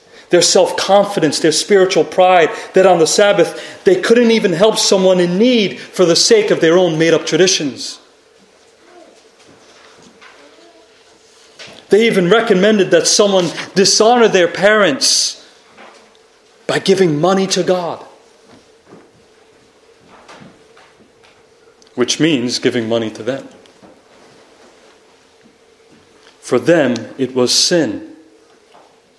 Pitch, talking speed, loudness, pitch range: 195 Hz, 105 wpm, -12 LUFS, 175-235 Hz